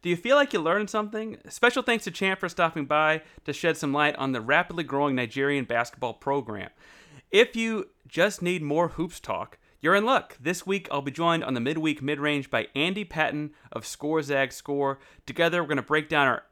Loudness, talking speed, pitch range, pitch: -26 LUFS, 210 wpm, 140-180 Hz, 155 Hz